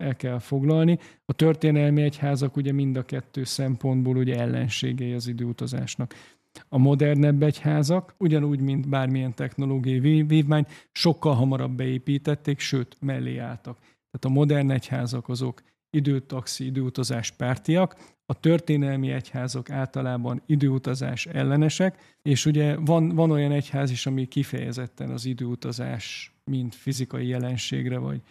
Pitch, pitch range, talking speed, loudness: 135 Hz, 125-150 Hz, 125 wpm, -25 LUFS